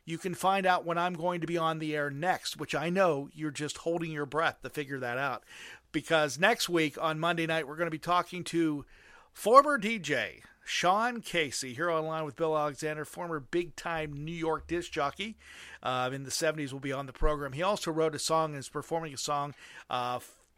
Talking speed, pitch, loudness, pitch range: 215 wpm, 160 Hz, -31 LUFS, 145-170 Hz